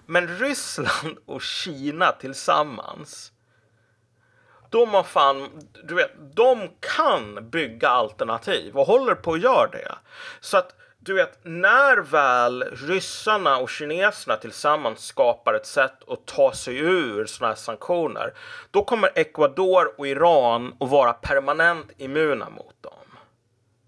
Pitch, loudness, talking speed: 180 Hz, -22 LUFS, 125 wpm